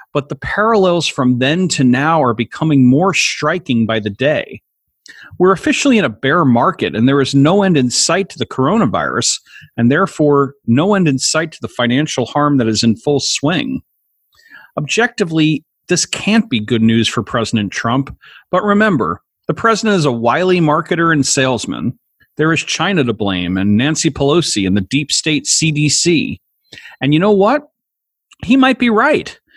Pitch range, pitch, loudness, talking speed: 125-180 Hz, 145 Hz, -14 LUFS, 170 wpm